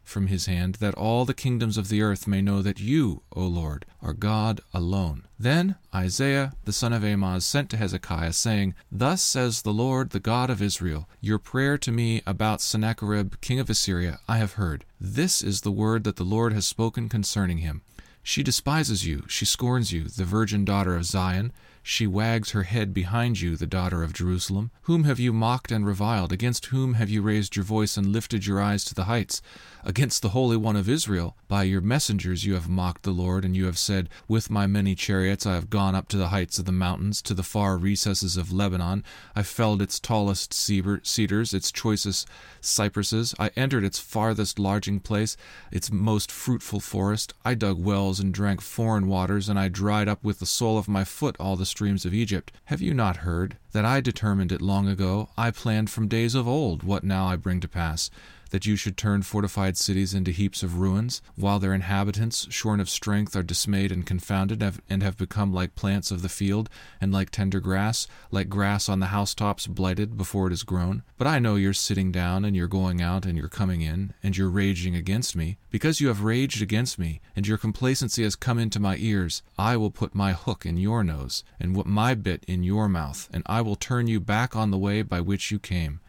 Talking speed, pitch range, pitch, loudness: 210 wpm, 95-110 Hz, 100 Hz, -26 LUFS